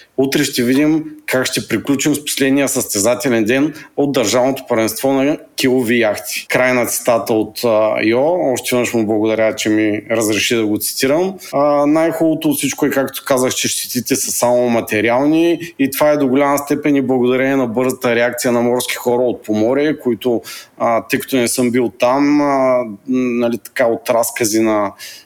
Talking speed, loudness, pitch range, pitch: 170 wpm, -15 LUFS, 115-140 Hz, 125 Hz